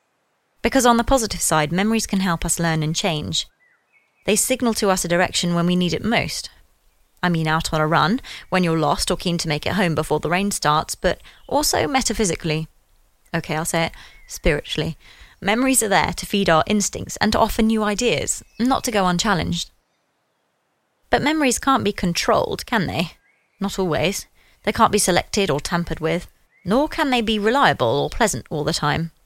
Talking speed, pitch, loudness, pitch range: 190 wpm, 180 Hz, -20 LUFS, 160-220 Hz